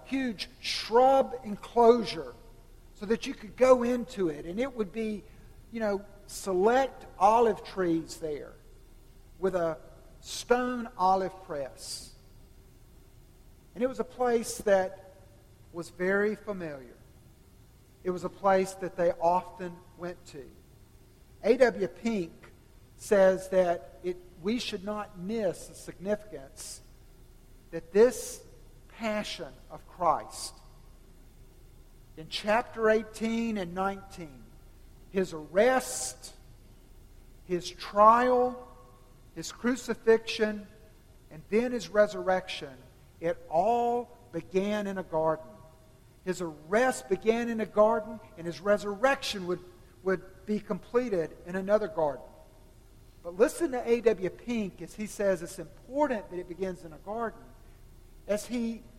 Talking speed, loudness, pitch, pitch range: 115 wpm, -29 LUFS, 190 Hz, 165-225 Hz